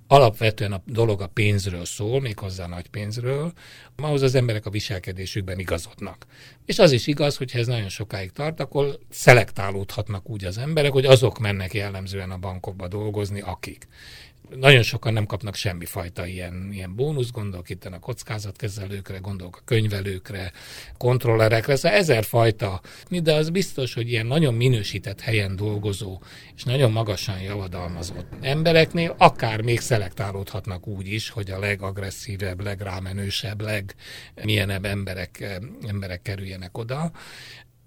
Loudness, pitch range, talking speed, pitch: -23 LUFS, 95-125 Hz, 140 wpm, 105 Hz